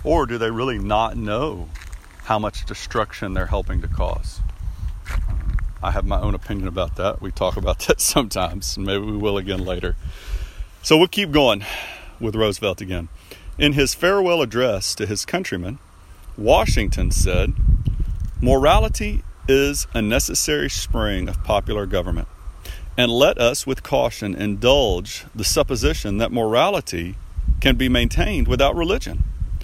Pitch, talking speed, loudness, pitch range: 95 Hz, 140 wpm, -21 LUFS, 85-110 Hz